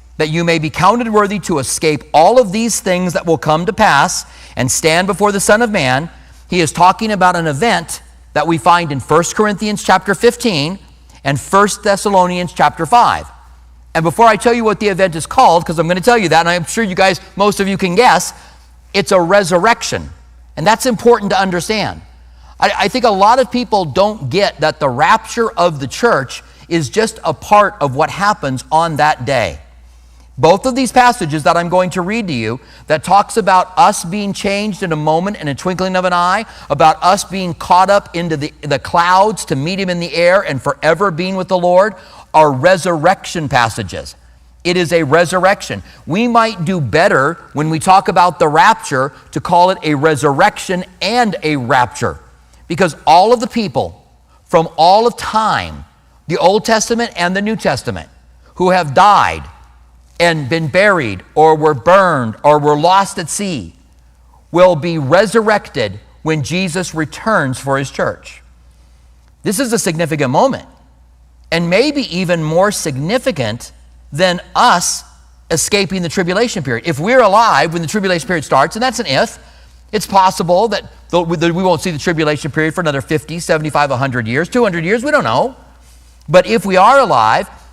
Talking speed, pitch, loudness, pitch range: 185 wpm, 175 Hz, -13 LUFS, 140-200 Hz